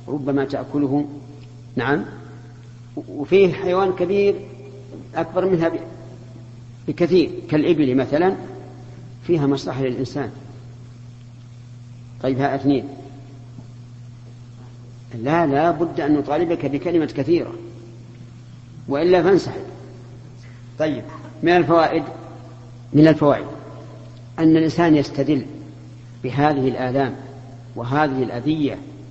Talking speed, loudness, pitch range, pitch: 80 wpm, -20 LUFS, 120-150 Hz, 130 Hz